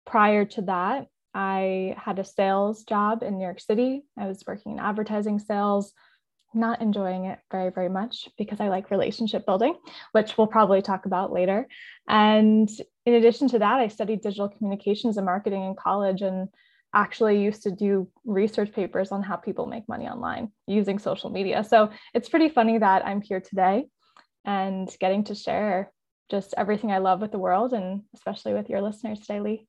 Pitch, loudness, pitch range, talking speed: 205 Hz, -25 LUFS, 195-225 Hz, 180 wpm